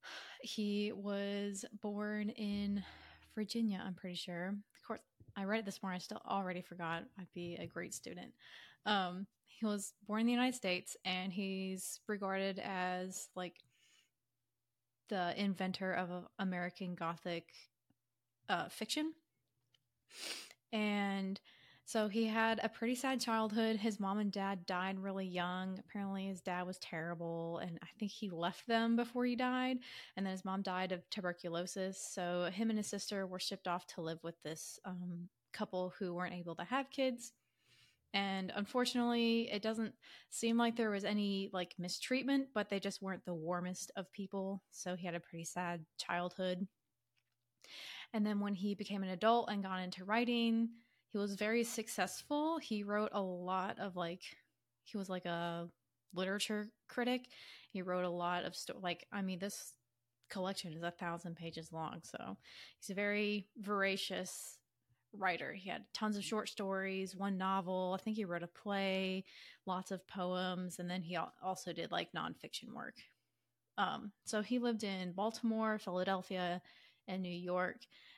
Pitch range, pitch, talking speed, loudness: 180-210 Hz, 195 Hz, 160 wpm, -40 LUFS